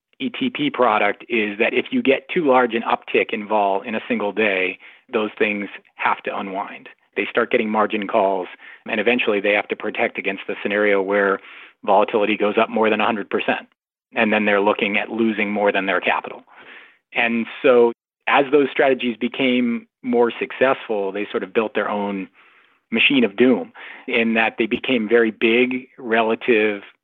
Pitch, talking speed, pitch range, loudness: 115 Hz, 170 wpm, 105-120 Hz, -19 LUFS